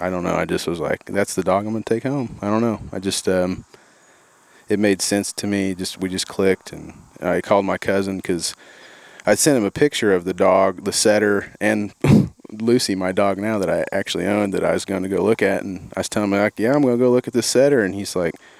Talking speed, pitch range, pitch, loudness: 260 wpm, 95-110 Hz, 100 Hz, -20 LUFS